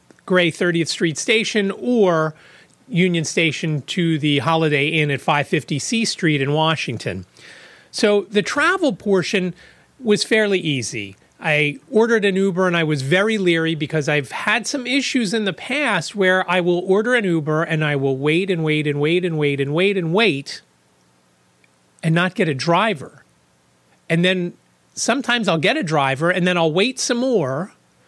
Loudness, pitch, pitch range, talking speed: -19 LUFS, 170 Hz, 150-200 Hz, 175 wpm